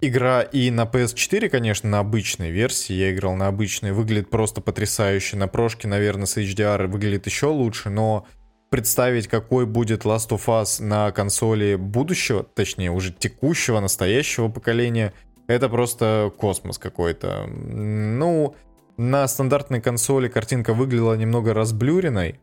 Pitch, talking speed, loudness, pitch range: 110 Hz, 135 wpm, -22 LUFS, 105-125 Hz